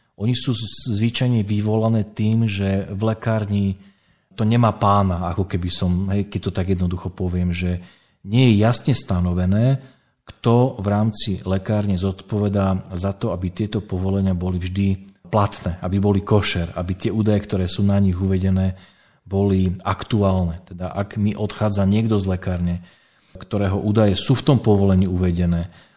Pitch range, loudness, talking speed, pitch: 95-110 Hz, -20 LUFS, 150 wpm, 100 Hz